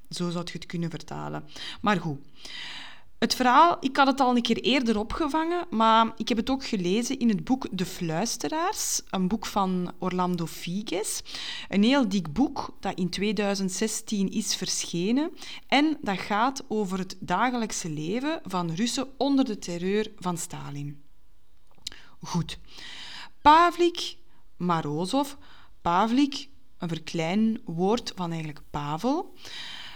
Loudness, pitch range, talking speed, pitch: -26 LUFS, 175-265 Hz, 135 wpm, 215 Hz